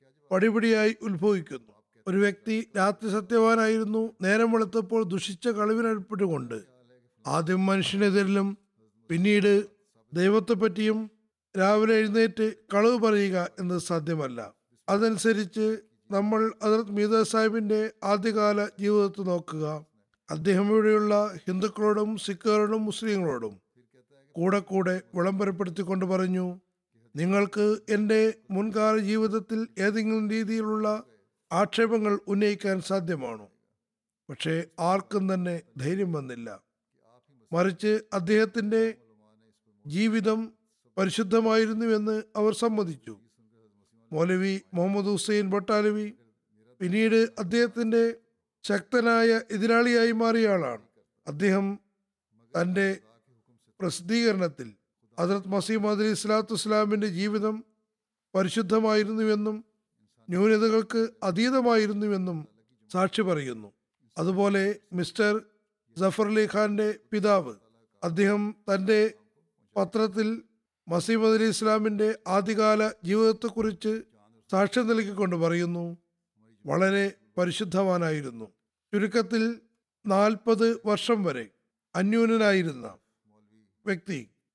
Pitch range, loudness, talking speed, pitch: 180-220 Hz, -26 LUFS, 75 wpm, 205 Hz